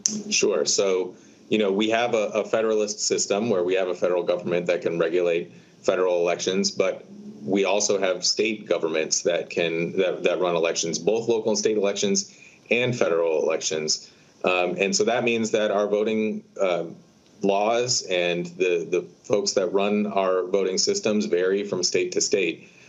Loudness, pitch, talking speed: -23 LUFS, 125 Hz, 170 wpm